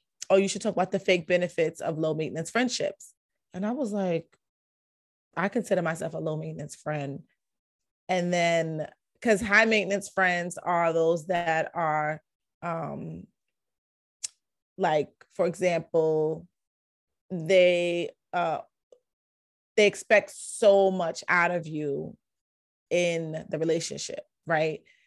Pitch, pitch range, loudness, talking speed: 175 Hz, 160-195 Hz, -27 LUFS, 120 wpm